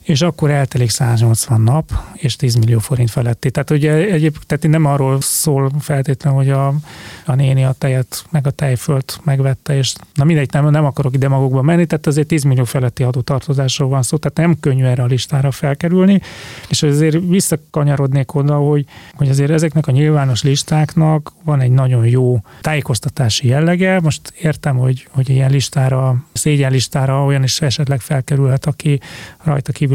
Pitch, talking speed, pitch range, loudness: 140 Hz, 165 wpm, 130-150 Hz, -15 LUFS